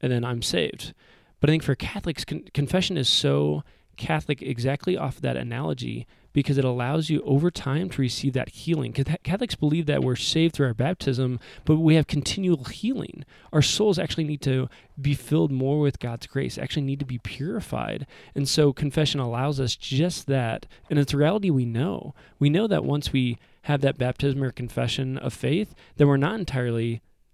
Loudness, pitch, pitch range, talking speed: -25 LUFS, 140 Hz, 125-155 Hz, 190 wpm